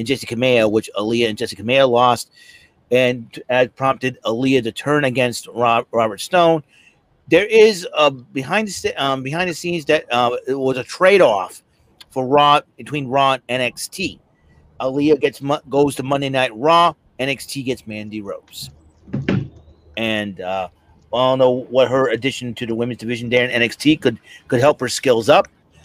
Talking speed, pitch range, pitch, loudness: 165 wpm, 115-140 Hz, 130 Hz, -18 LUFS